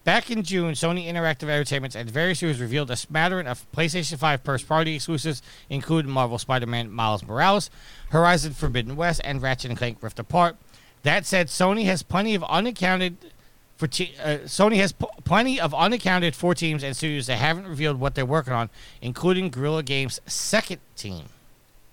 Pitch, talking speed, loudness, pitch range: 155 Hz, 170 wpm, -24 LUFS, 130-175 Hz